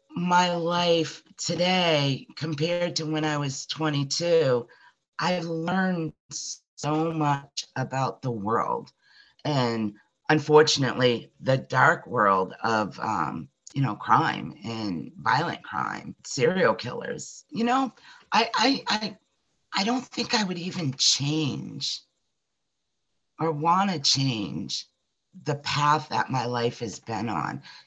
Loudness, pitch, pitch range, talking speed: -26 LUFS, 155 Hz, 130-175 Hz, 120 wpm